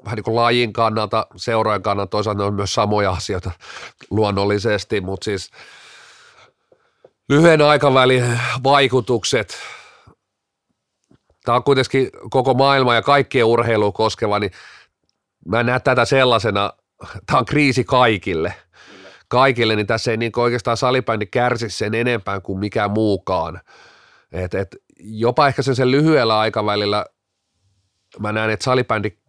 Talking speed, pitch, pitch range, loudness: 115 wpm, 115 Hz, 105-130 Hz, -18 LUFS